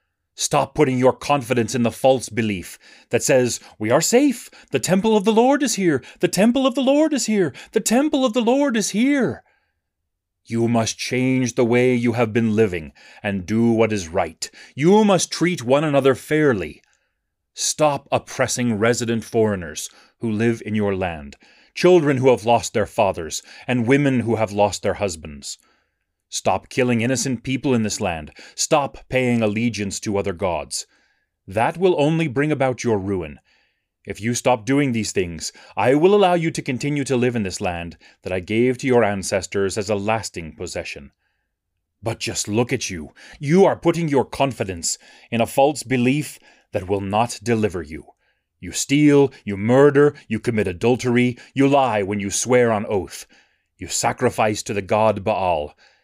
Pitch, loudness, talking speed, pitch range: 120 Hz, -20 LUFS, 175 wpm, 105-140 Hz